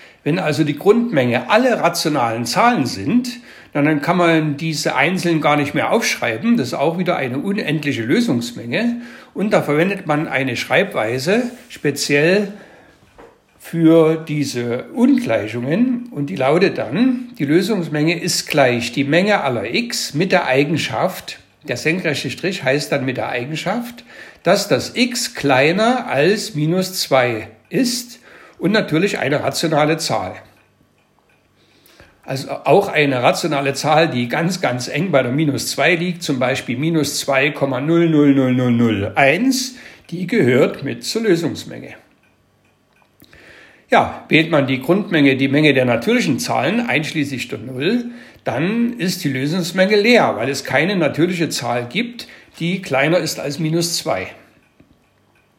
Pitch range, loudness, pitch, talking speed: 135-190 Hz, -17 LUFS, 155 Hz, 135 wpm